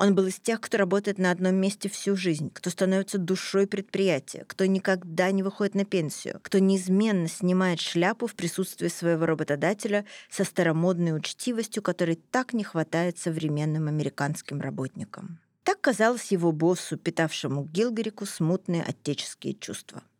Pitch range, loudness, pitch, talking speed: 165-200 Hz, -27 LUFS, 185 Hz, 145 wpm